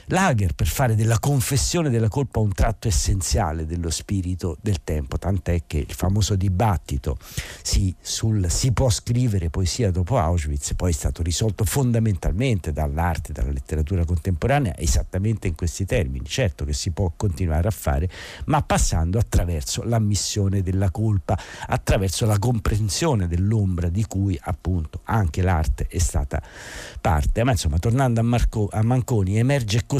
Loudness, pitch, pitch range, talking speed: -23 LUFS, 95 Hz, 85-110 Hz, 150 wpm